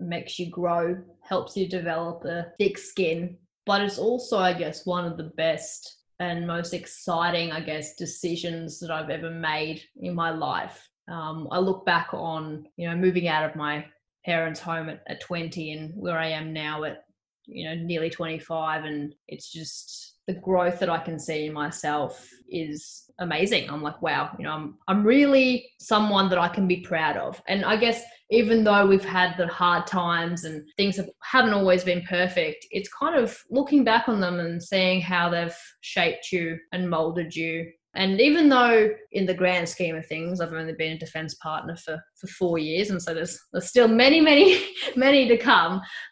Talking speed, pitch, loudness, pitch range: 190 wpm, 175 Hz, -24 LUFS, 160-195 Hz